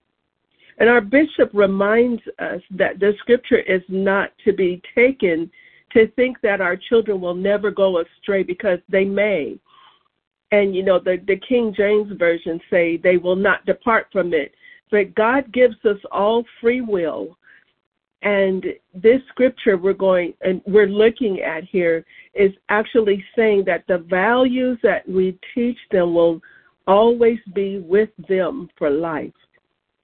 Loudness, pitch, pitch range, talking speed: -18 LUFS, 200 Hz, 185-230 Hz, 150 wpm